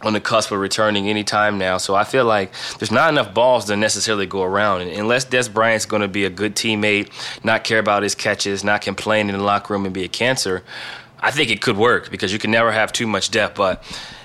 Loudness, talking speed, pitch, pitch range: -18 LUFS, 250 wpm, 105 Hz, 100-110 Hz